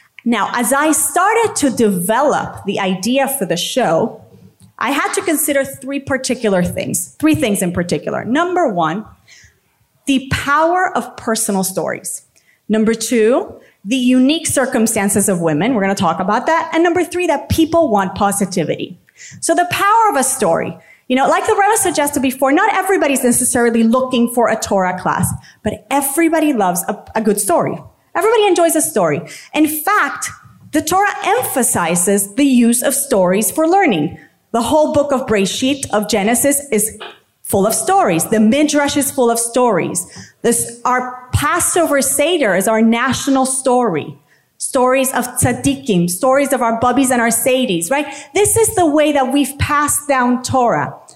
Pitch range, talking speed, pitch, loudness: 220-300 Hz, 160 wpm, 260 Hz, -15 LUFS